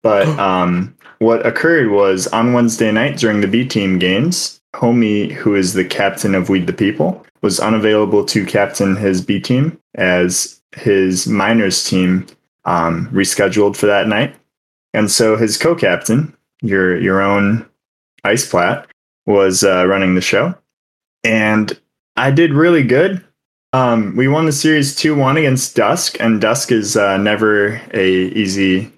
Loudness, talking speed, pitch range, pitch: -14 LUFS, 150 wpm, 95-120 Hz, 105 Hz